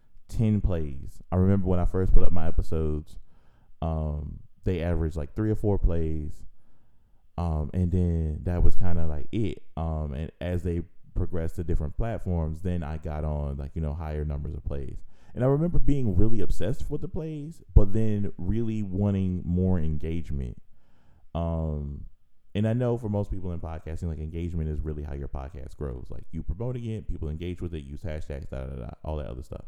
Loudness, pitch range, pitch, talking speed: -30 LUFS, 75-100 Hz, 85 Hz, 190 wpm